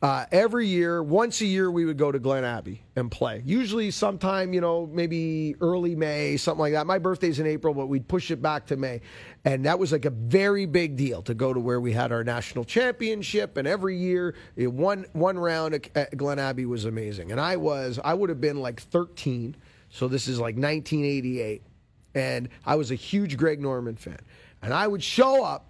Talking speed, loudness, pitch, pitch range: 210 wpm, -26 LUFS, 150 Hz, 125-180 Hz